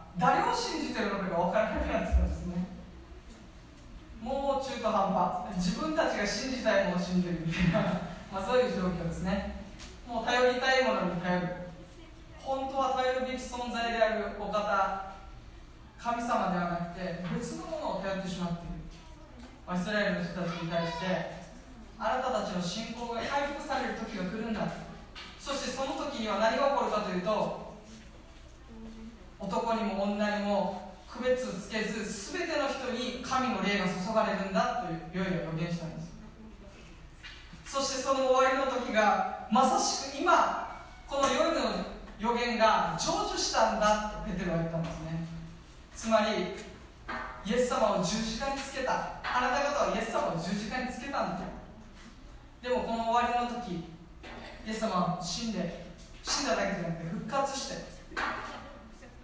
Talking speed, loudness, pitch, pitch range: 310 characters per minute, -31 LUFS, 215 Hz, 180-250 Hz